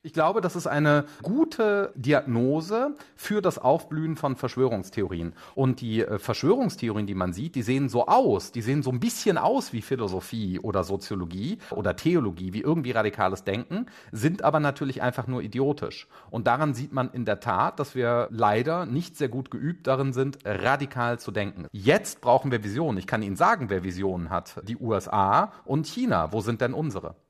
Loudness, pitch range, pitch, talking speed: -26 LUFS, 105-150 Hz, 130 Hz, 180 wpm